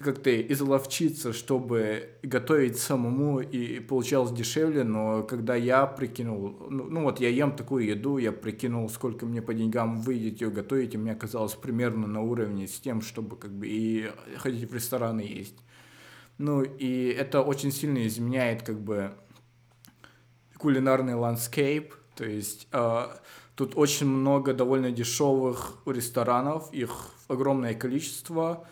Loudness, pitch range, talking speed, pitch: -28 LUFS, 115-135 Hz, 140 wpm, 125 Hz